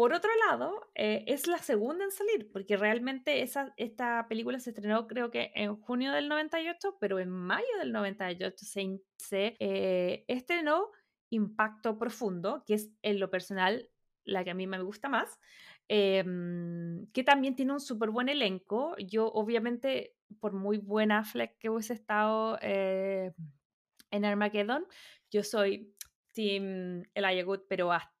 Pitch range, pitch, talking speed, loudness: 195-250 Hz, 215 Hz, 155 wpm, -32 LUFS